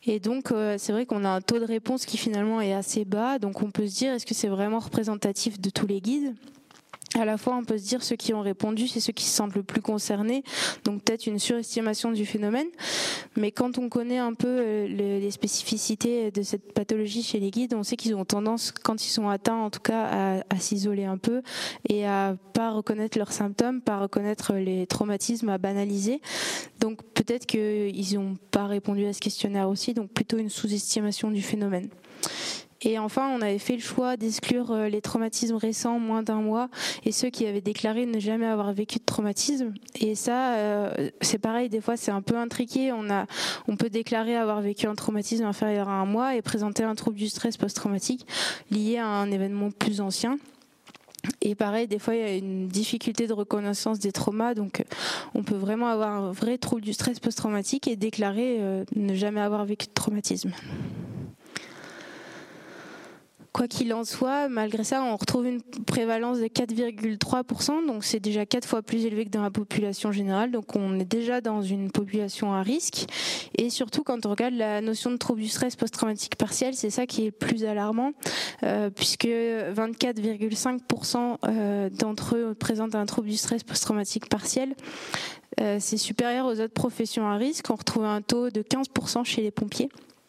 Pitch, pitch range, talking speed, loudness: 225 Hz, 210-240 Hz, 190 wpm, -27 LUFS